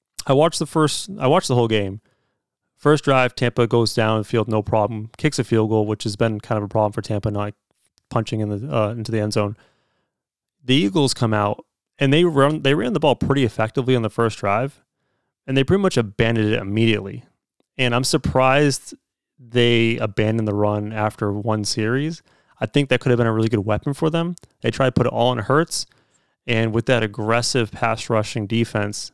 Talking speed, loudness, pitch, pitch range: 210 wpm, -20 LUFS, 115 Hz, 110-130 Hz